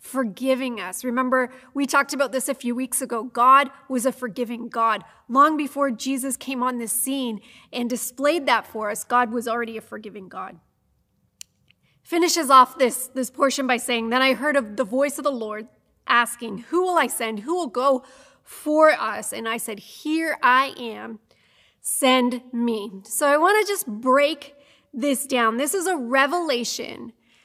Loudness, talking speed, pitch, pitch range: -22 LUFS, 175 wpm, 255 Hz, 235-280 Hz